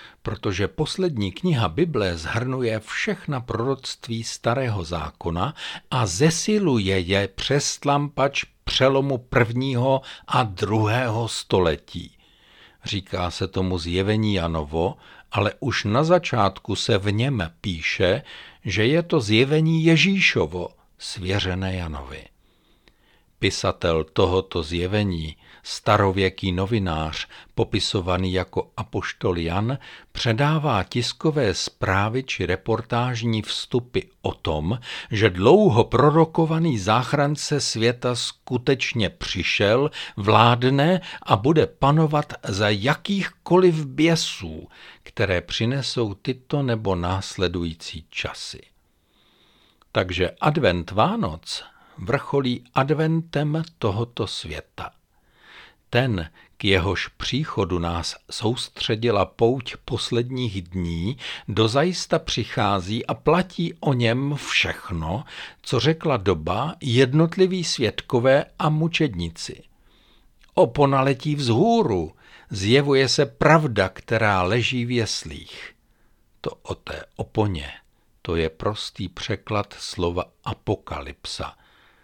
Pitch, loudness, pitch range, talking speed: 120 Hz, -22 LUFS, 95-145 Hz, 90 wpm